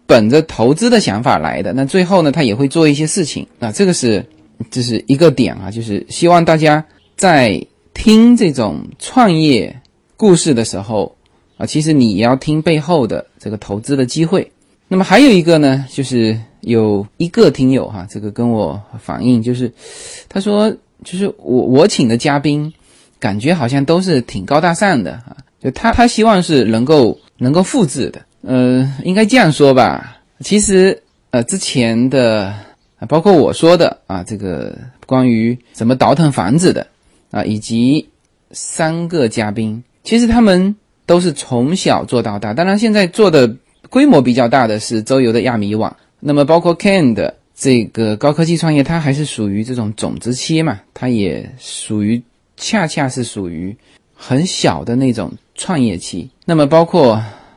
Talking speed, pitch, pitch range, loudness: 245 characters per minute, 135 Hz, 115-175 Hz, -13 LUFS